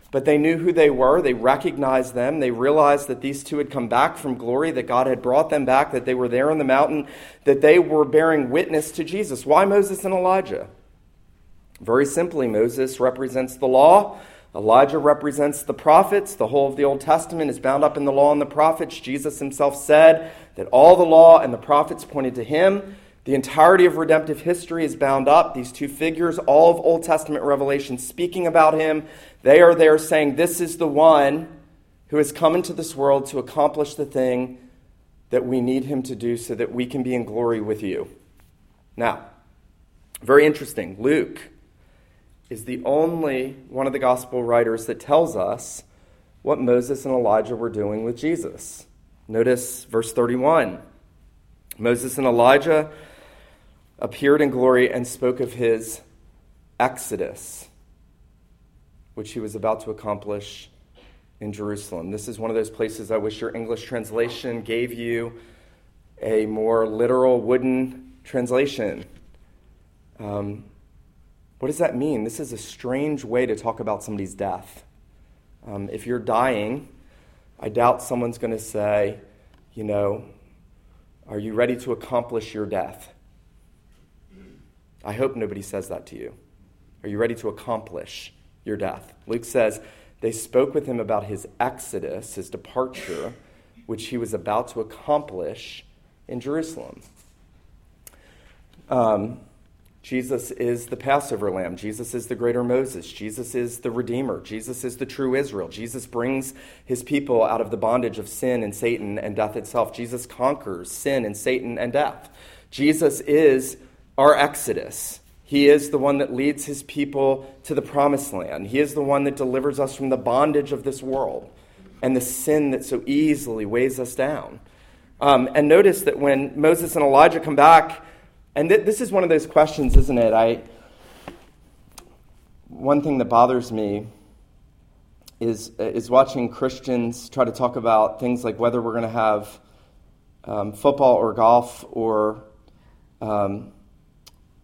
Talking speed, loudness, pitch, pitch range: 160 wpm, -20 LUFS, 125 Hz, 110-145 Hz